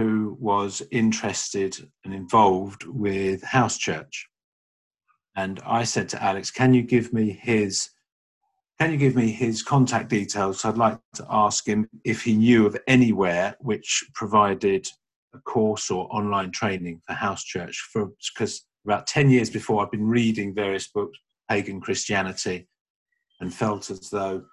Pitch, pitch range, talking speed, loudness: 110 Hz, 100-125 Hz, 155 wpm, -24 LUFS